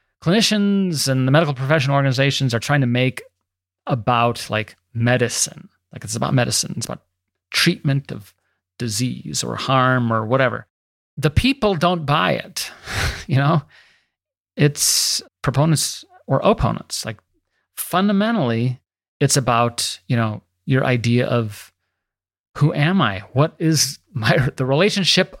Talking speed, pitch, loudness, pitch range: 130 wpm, 135 Hz, -19 LUFS, 115-155 Hz